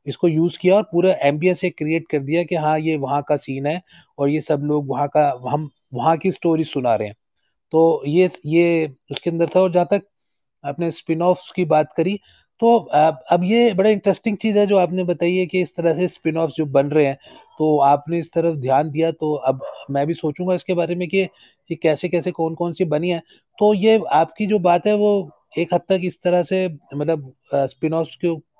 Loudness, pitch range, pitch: -19 LUFS, 150-180 Hz, 165 Hz